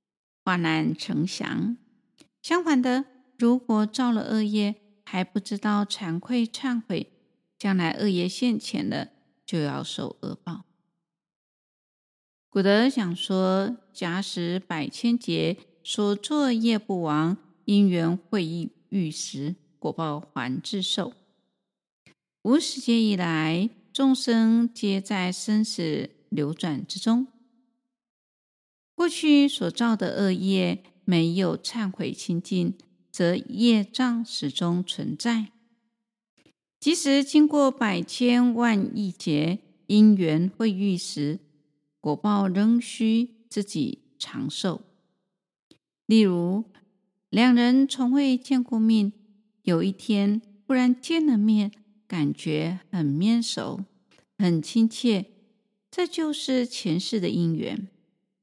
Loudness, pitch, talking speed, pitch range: -25 LUFS, 210 Hz, 150 characters per minute, 180-235 Hz